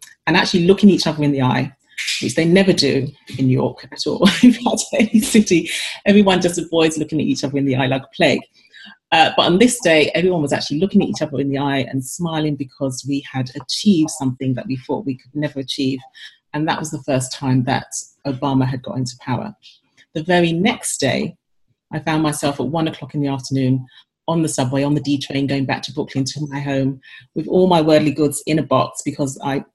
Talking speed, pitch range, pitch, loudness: 225 wpm, 135-165 Hz, 145 Hz, -18 LUFS